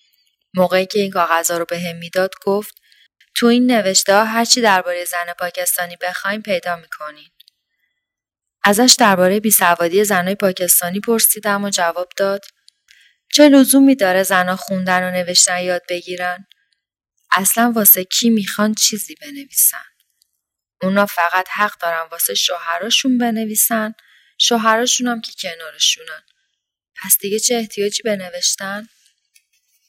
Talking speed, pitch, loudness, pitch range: 120 wpm, 195 Hz, -15 LUFS, 180-220 Hz